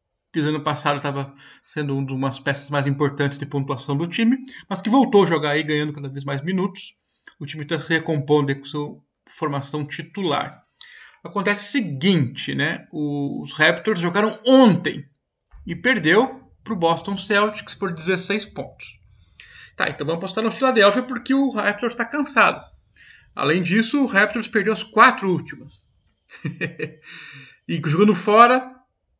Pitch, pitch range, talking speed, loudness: 170 Hz, 145-220 Hz, 150 wpm, -20 LUFS